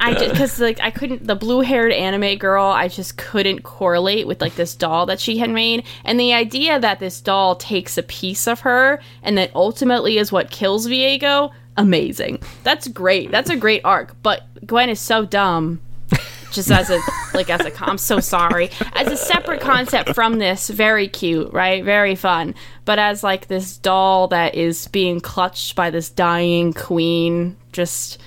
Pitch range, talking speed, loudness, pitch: 175-230 Hz, 185 wpm, -17 LUFS, 195 Hz